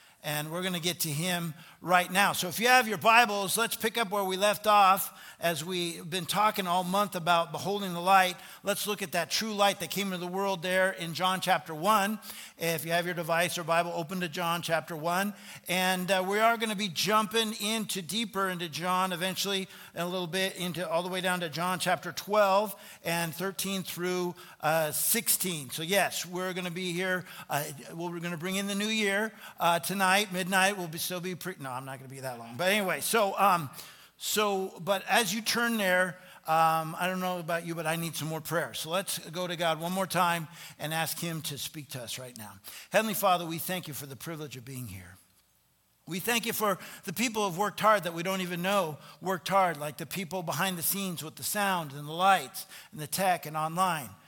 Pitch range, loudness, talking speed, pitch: 165-195 Hz, -29 LUFS, 230 wpm, 180 Hz